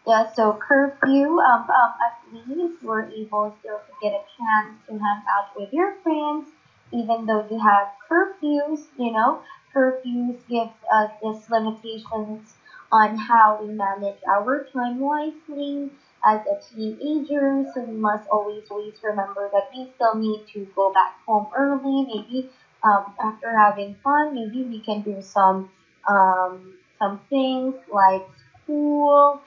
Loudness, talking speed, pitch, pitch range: -22 LUFS, 145 wpm, 225 Hz, 210-275 Hz